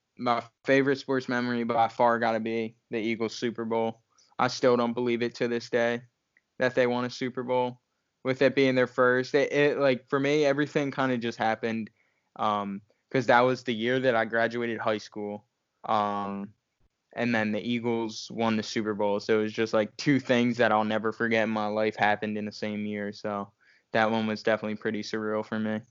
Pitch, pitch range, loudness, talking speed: 115 Hz, 110-125 Hz, -27 LUFS, 210 wpm